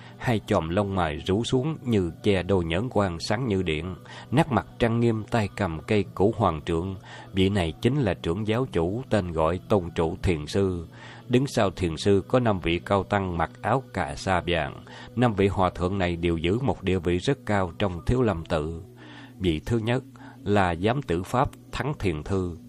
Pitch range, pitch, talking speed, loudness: 85-120 Hz, 100 Hz, 205 wpm, -26 LUFS